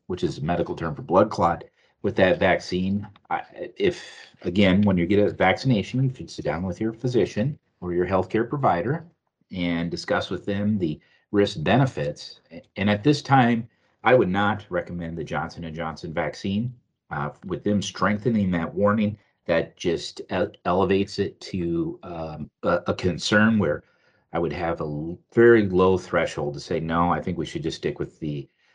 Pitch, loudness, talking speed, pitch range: 100 Hz, -24 LUFS, 170 wpm, 85-110 Hz